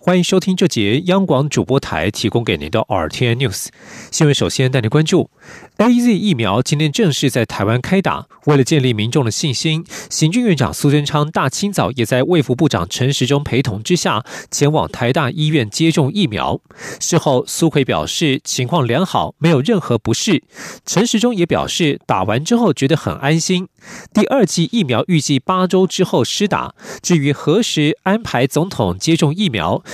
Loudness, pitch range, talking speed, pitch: -16 LUFS, 125-180 Hz, 285 characters per minute, 150 Hz